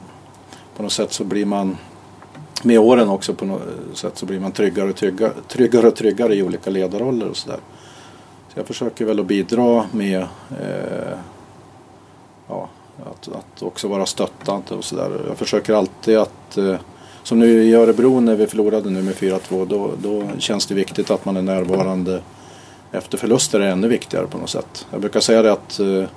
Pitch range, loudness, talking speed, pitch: 95-115 Hz, -18 LUFS, 185 wpm, 105 Hz